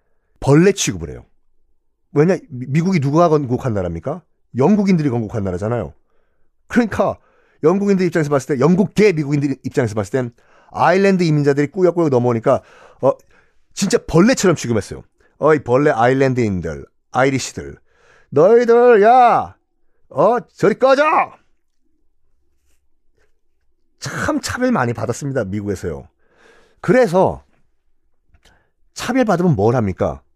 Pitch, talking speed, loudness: 145 Hz, 285 characters per minute, -16 LUFS